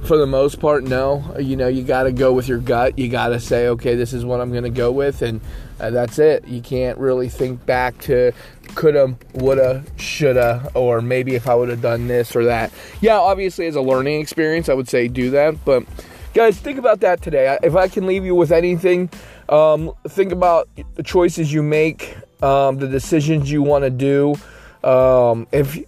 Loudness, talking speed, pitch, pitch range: -17 LUFS, 200 wpm, 135 Hz, 125-155 Hz